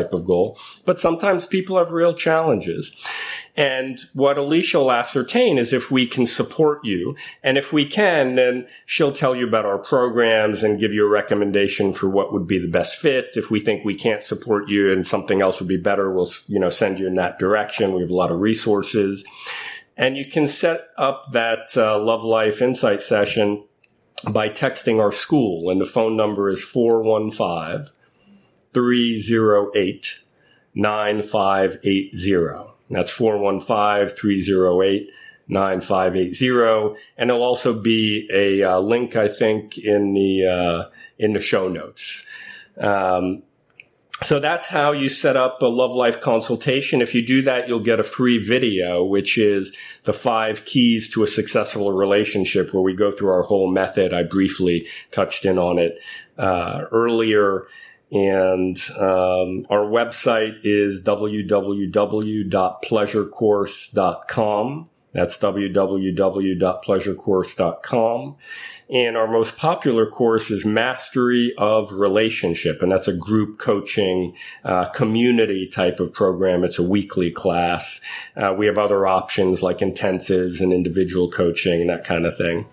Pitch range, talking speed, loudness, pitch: 95-125 Hz, 145 wpm, -20 LUFS, 105 Hz